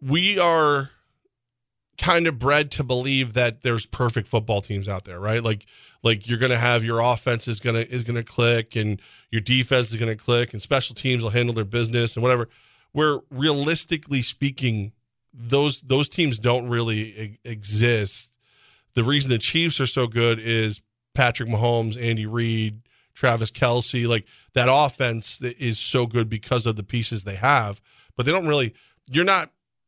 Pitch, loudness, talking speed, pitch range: 120 Hz, -22 LUFS, 180 wpm, 115-130 Hz